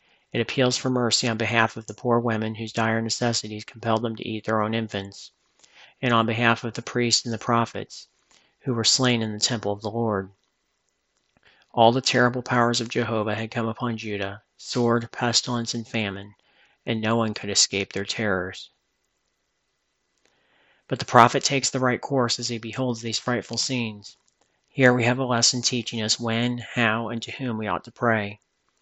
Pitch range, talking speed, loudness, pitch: 110-120 Hz, 185 wpm, -23 LUFS, 115 Hz